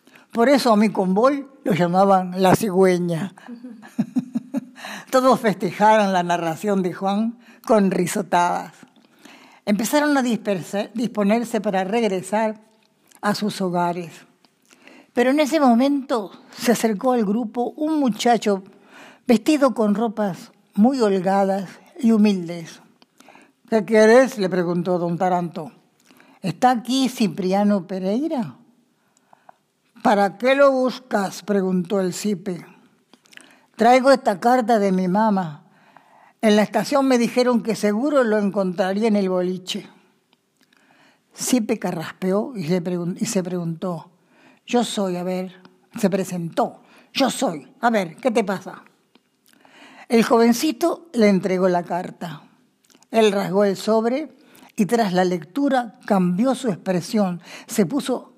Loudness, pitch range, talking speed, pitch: -20 LUFS, 190-245 Hz, 115 wpm, 215 Hz